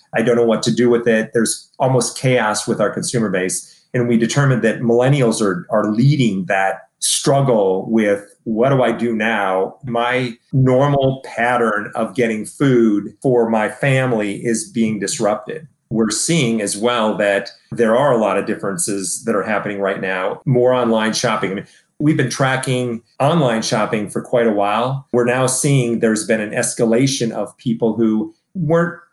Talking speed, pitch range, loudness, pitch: 175 wpm, 110-130 Hz, -17 LUFS, 115 Hz